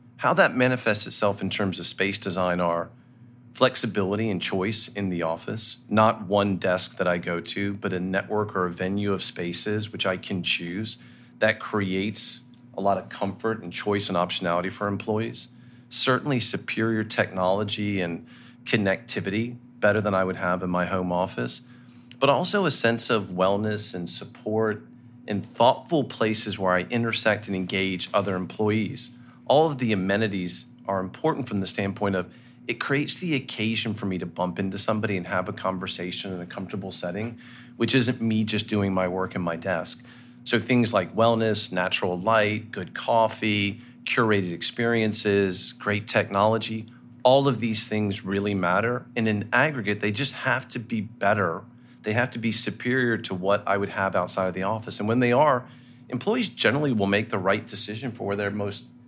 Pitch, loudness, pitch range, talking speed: 105 Hz, -25 LUFS, 95-120 Hz, 175 wpm